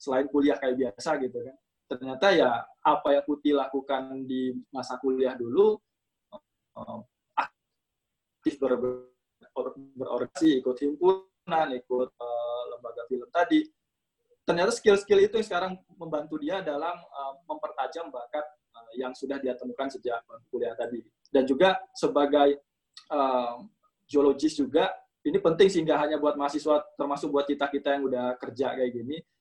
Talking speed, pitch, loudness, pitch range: 135 wpm, 140 Hz, -28 LUFS, 130-175 Hz